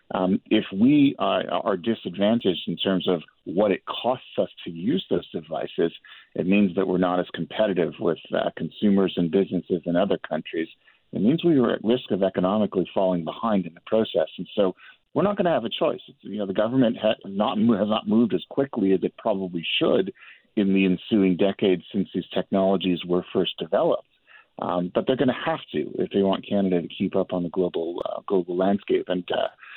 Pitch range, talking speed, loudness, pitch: 90-105 Hz, 205 wpm, -24 LUFS, 95 Hz